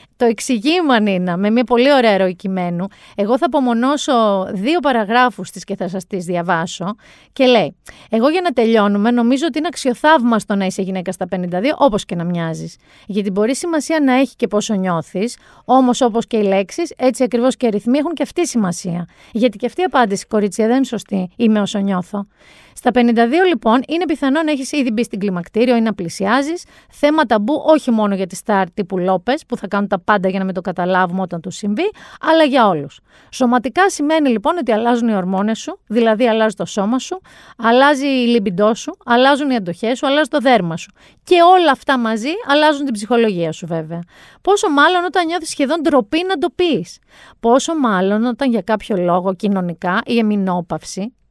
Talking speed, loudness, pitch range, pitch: 190 wpm, -16 LUFS, 195-280 Hz, 230 Hz